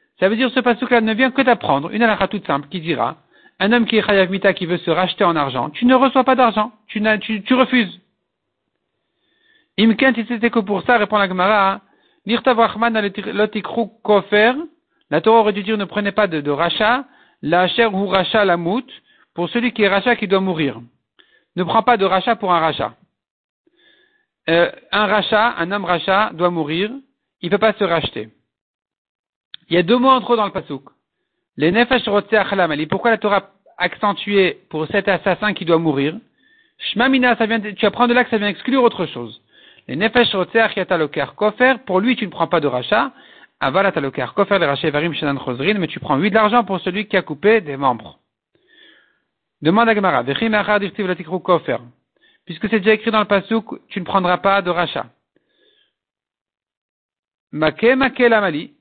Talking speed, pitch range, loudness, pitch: 185 wpm, 180-235 Hz, -17 LUFS, 210 Hz